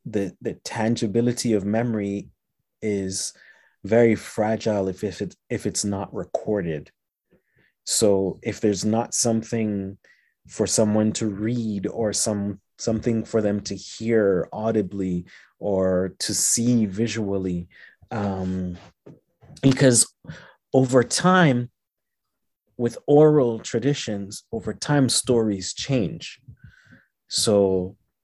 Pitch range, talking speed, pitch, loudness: 100-115 Hz, 100 wpm, 110 Hz, -23 LUFS